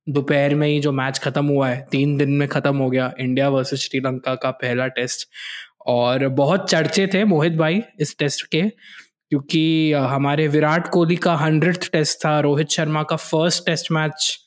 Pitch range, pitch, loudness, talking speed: 140-160 Hz, 150 Hz, -19 LUFS, 180 wpm